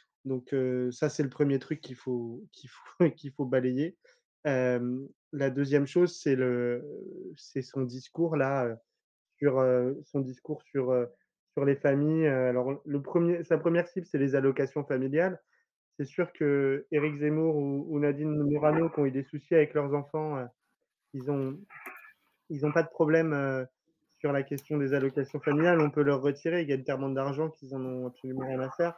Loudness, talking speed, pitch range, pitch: -30 LUFS, 185 wpm, 135-155 Hz, 140 Hz